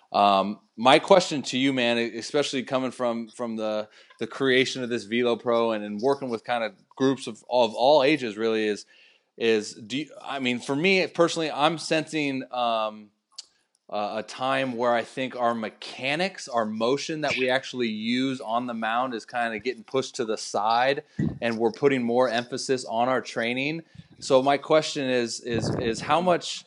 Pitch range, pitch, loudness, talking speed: 115-140 Hz, 125 Hz, -25 LUFS, 185 wpm